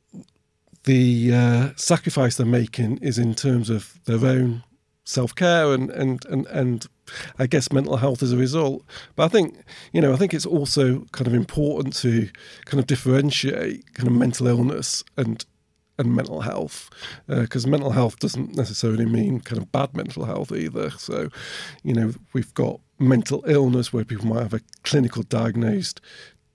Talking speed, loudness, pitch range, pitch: 165 wpm, -22 LUFS, 115-140 Hz, 125 Hz